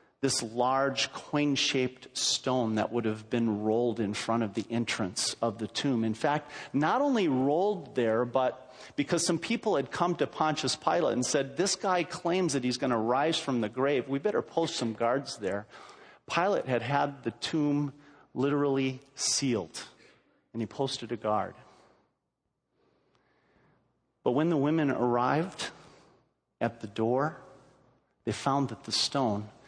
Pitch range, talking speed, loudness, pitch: 115-145 Hz, 155 wpm, -30 LUFS, 135 Hz